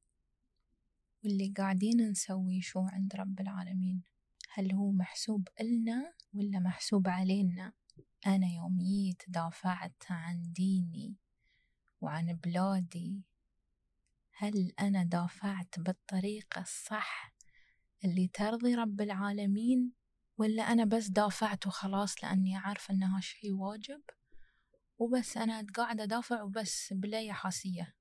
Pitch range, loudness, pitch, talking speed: 185-215 Hz, -35 LUFS, 195 Hz, 105 wpm